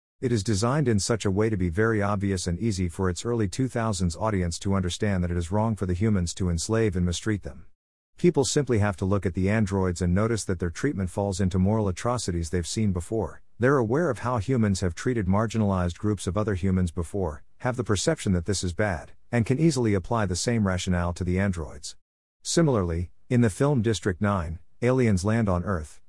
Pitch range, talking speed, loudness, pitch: 90-115 Hz, 210 wpm, -26 LUFS, 100 Hz